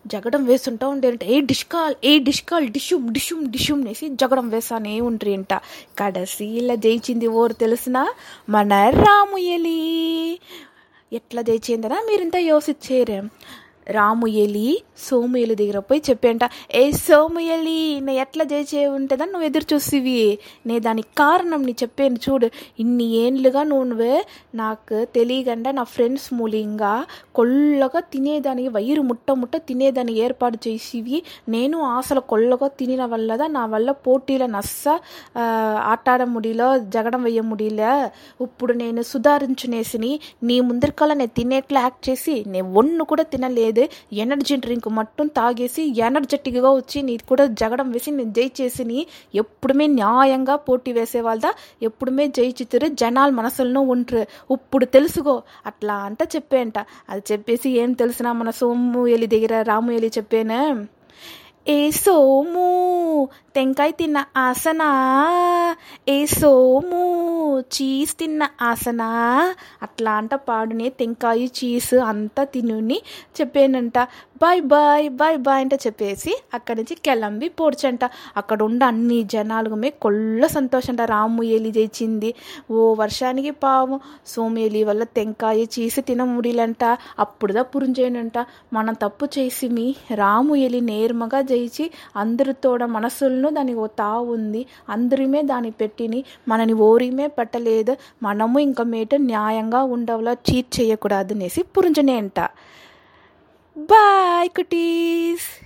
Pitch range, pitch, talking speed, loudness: 230-285 Hz, 255 Hz, 105 wpm, -20 LUFS